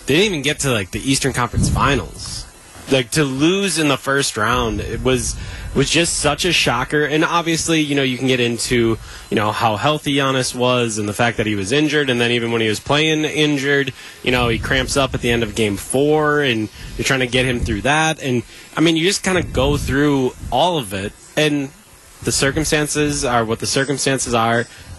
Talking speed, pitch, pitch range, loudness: 225 wpm, 130 Hz, 115-150 Hz, -17 LUFS